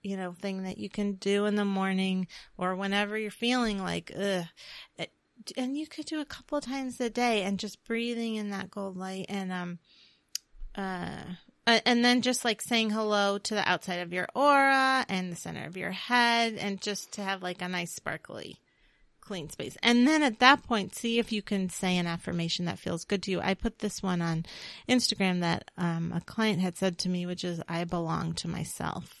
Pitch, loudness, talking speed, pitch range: 195 Hz, -29 LUFS, 210 wpm, 180-230 Hz